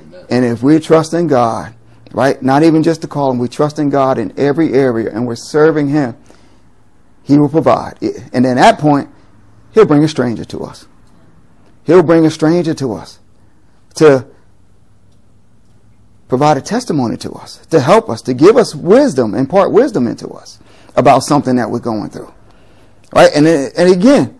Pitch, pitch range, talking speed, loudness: 135 Hz, 115-160 Hz, 175 wpm, -12 LUFS